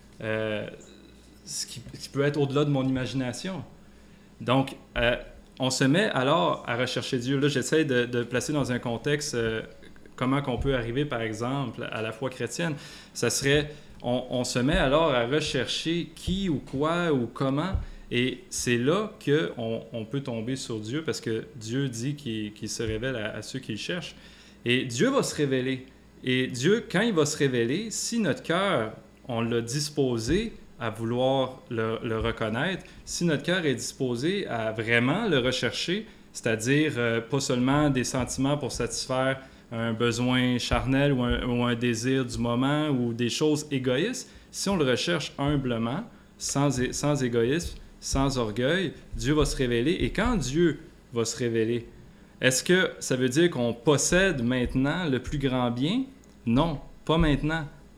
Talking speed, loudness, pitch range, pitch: 175 wpm, -27 LUFS, 120-150 Hz, 130 Hz